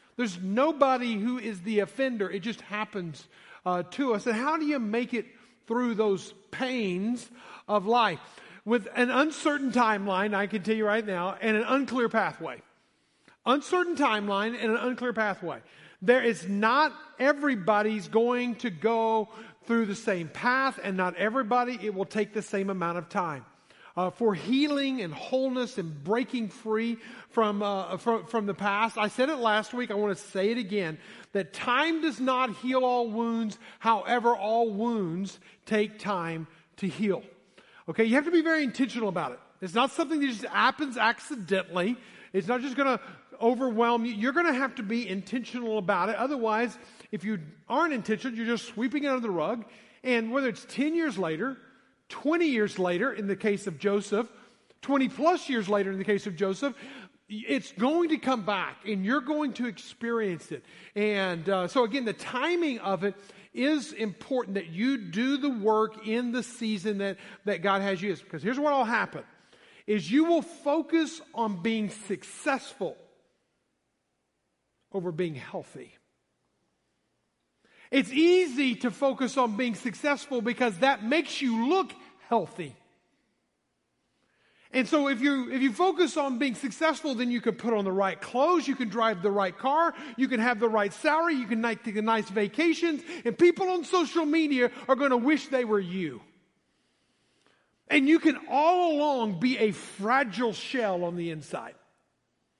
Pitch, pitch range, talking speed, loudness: 230 Hz, 205-265 Hz, 170 wpm, -28 LUFS